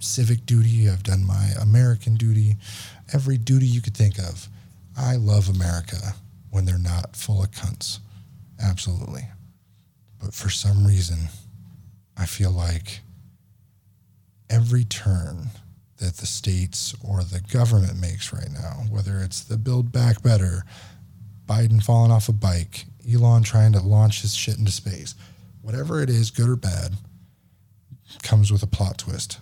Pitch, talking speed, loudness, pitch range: 105 Hz, 145 wpm, -22 LUFS, 95-115 Hz